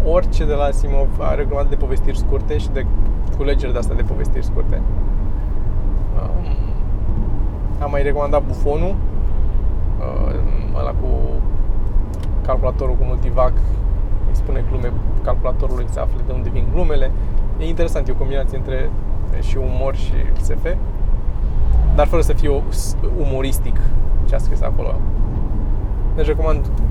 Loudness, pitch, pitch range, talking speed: -21 LUFS, 100 Hz, 90-105 Hz, 125 wpm